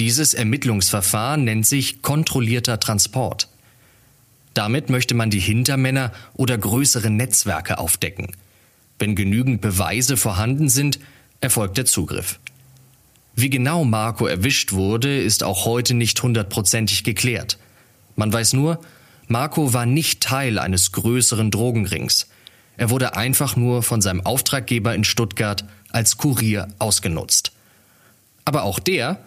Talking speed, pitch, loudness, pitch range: 120 wpm, 120 Hz, -19 LUFS, 105-130 Hz